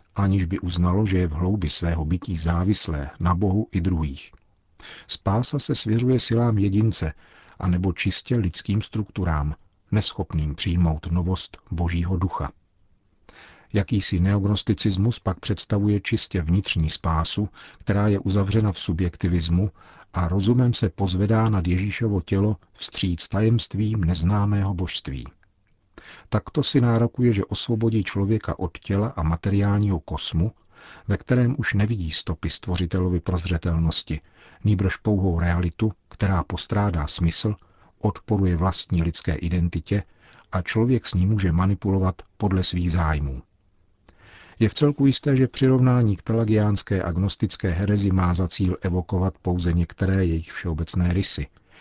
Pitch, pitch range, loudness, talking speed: 95 Hz, 85-105 Hz, -23 LUFS, 125 wpm